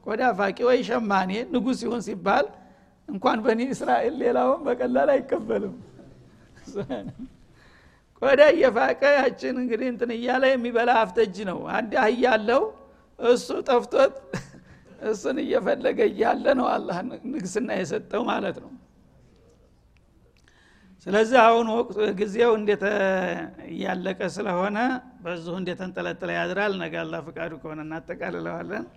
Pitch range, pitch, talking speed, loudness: 190-250 Hz, 225 Hz, 105 wpm, -24 LUFS